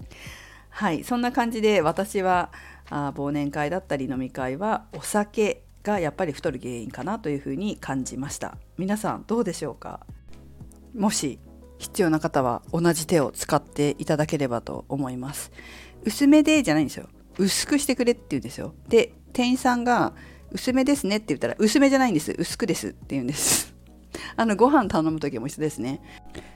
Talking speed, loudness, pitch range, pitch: 350 characters per minute, -24 LUFS, 135-220 Hz, 160 Hz